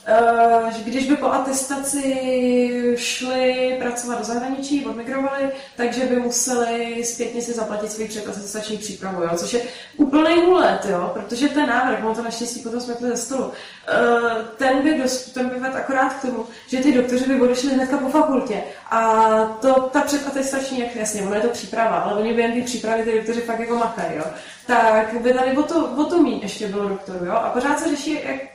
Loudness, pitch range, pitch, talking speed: -20 LUFS, 225-265 Hz, 240 Hz, 190 wpm